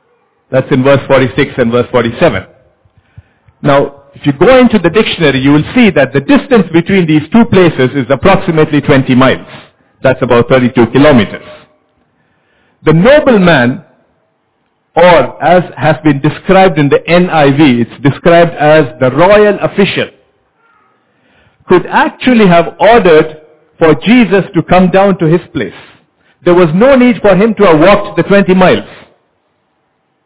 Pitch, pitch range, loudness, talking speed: 160 Hz, 140-195 Hz, -8 LUFS, 145 wpm